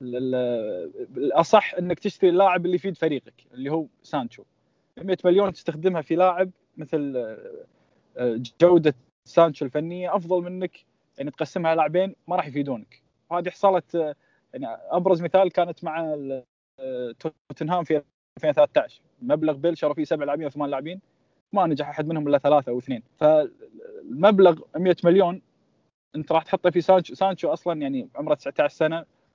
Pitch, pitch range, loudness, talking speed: 170 Hz, 150-190 Hz, -23 LUFS, 135 wpm